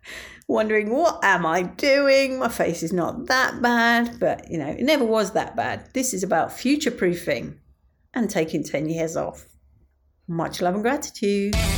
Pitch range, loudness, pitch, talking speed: 165-250 Hz, -22 LUFS, 215 Hz, 170 wpm